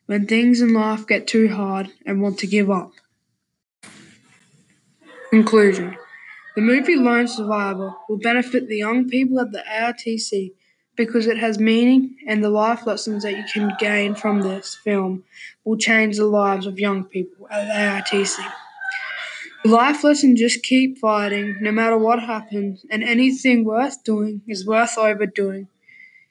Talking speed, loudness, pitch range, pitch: 155 wpm, -19 LUFS, 205-235 Hz, 220 Hz